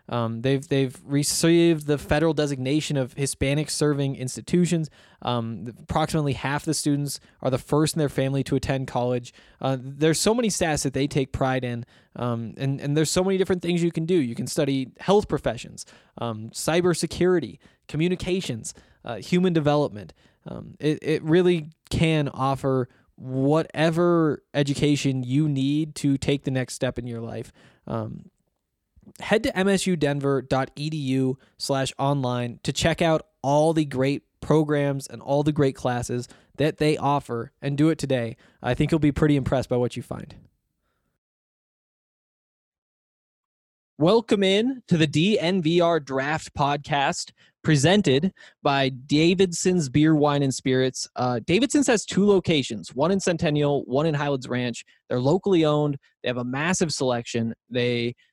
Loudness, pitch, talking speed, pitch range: -24 LUFS, 145 Hz, 150 wpm, 130-160 Hz